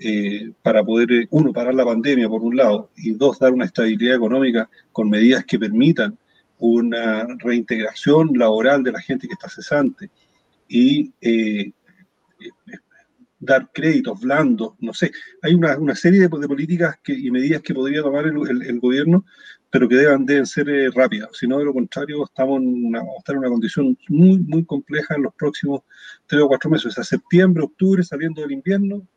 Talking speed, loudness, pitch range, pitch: 190 wpm, -18 LUFS, 125-175 Hz, 140 Hz